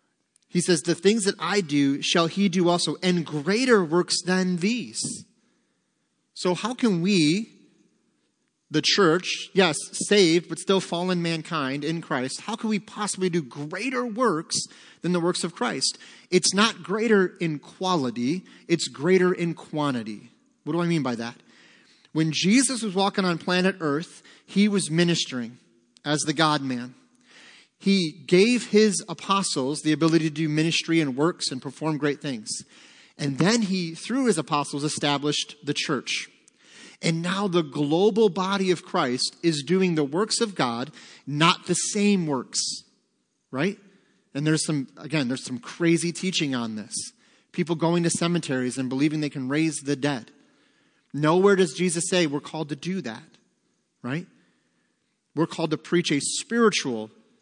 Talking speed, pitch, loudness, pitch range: 155 wpm, 170 Hz, -24 LUFS, 150-195 Hz